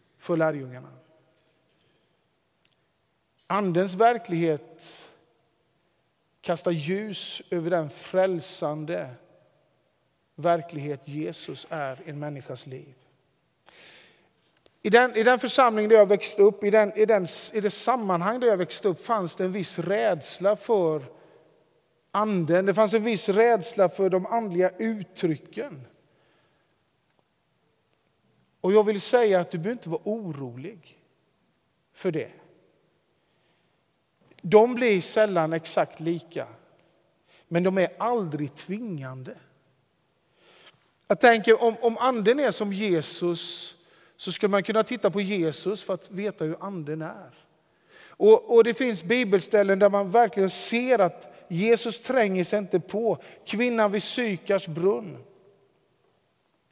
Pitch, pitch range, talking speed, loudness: 195 Hz, 165-220 Hz, 120 wpm, -24 LUFS